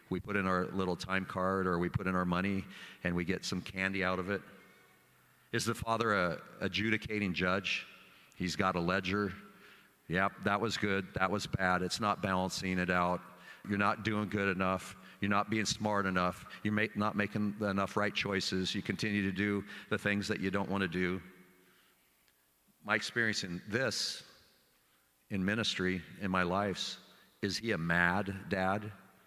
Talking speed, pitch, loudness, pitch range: 175 wpm, 95 Hz, -34 LUFS, 90-105 Hz